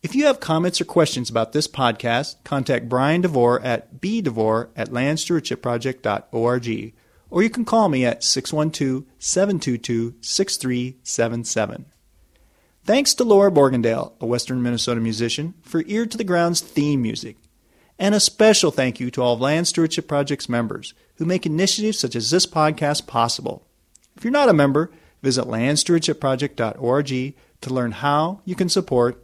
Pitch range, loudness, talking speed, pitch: 120-170 Hz, -20 LUFS, 150 wpm, 140 Hz